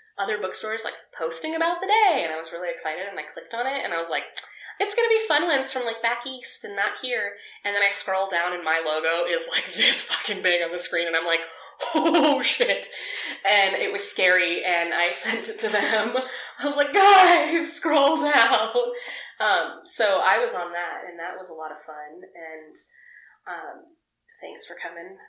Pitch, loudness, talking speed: 230 Hz, -22 LUFS, 210 wpm